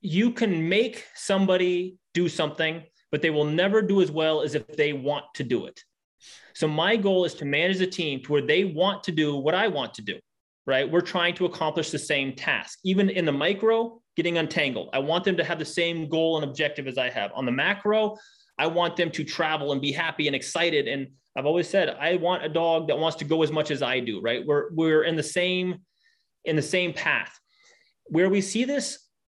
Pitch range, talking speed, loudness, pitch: 150-185 Hz, 225 wpm, -25 LUFS, 165 Hz